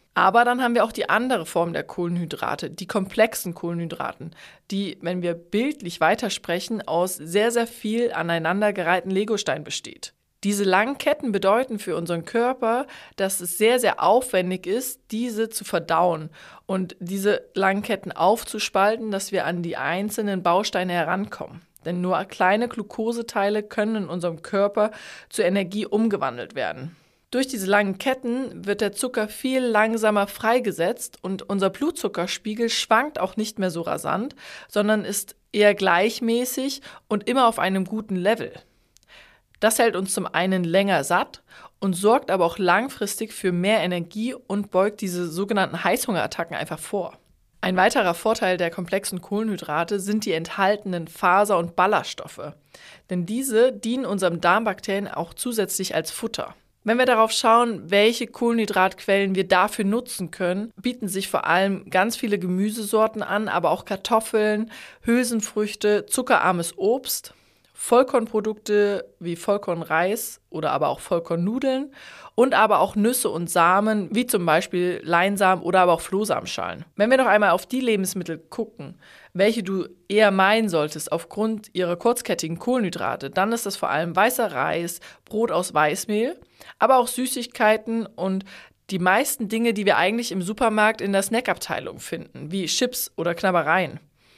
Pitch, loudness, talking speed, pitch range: 205 Hz, -23 LUFS, 145 wpm, 180-225 Hz